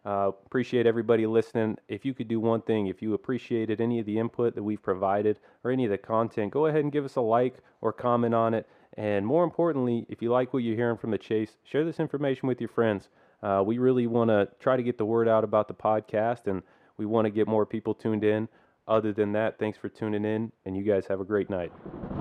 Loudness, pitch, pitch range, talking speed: -28 LUFS, 110 Hz, 105-120 Hz, 245 wpm